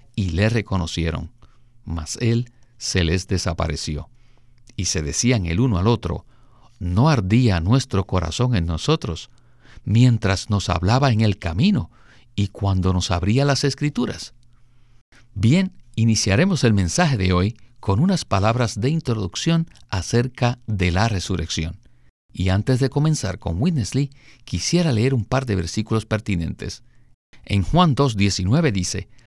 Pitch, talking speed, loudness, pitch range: 115 Hz, 135 wpm, -21 LUFS, 95-125 Hz